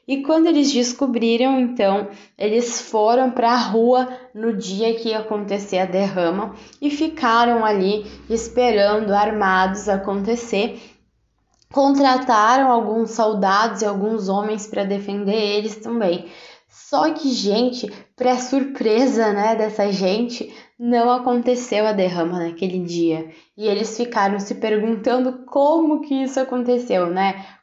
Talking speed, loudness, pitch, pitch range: 125 wpm, -19 LUFS, 225 Hz, 200-245 Hz